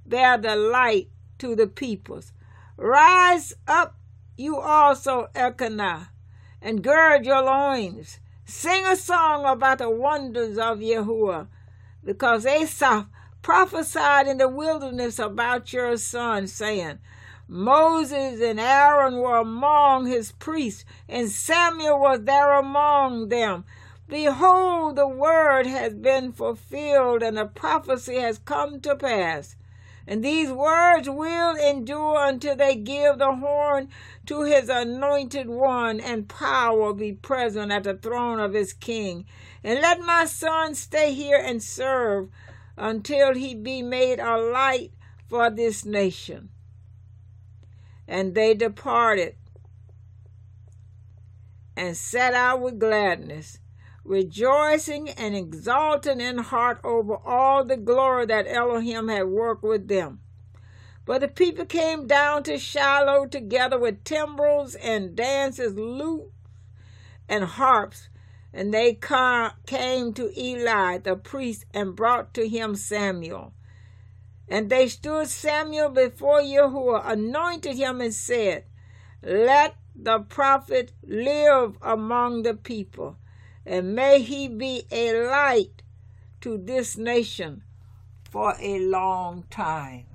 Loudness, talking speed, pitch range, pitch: -22 LUFS, 120 wpm, 205-280 Hz, 245 Hz